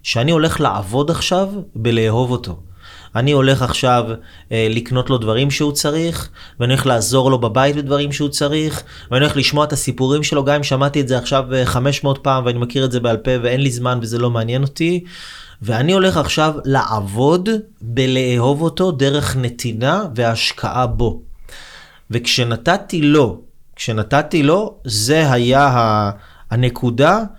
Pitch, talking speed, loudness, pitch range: 130 Hz, 145 wpm, -16 LUFS, 120-145 Hz